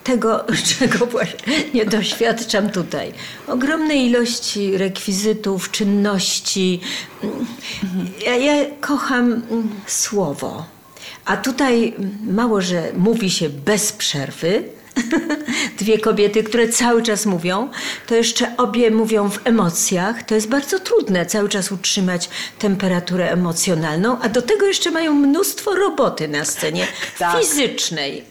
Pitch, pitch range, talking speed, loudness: 220 Hz, 195-250 Hz, 110 wpm, -18 LUFS